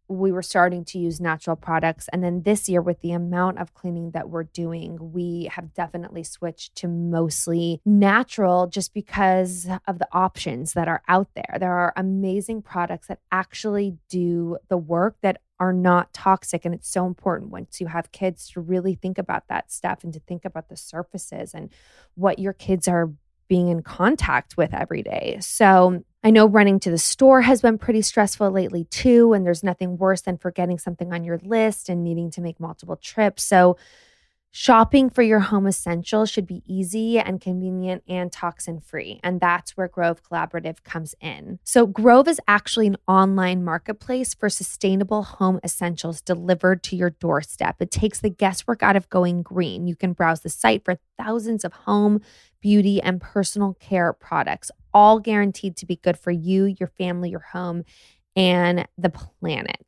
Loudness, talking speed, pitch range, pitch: -21 LUFS, 180 wpm, 175-200 Hz, 185 Hz